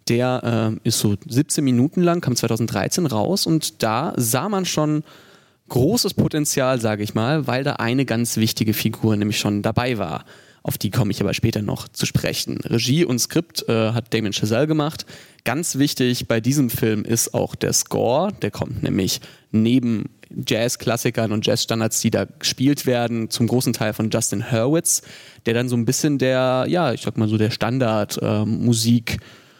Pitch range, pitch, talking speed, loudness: 110-135 Hz, 120 Hz, 175 wpm, -20 LUFS